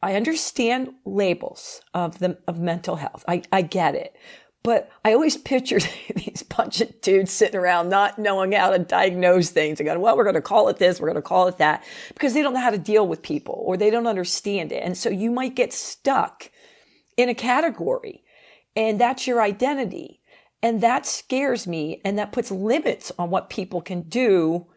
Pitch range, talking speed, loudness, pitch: 180-255 Hz, 195 wpm, -22 LUFS, 215 Hz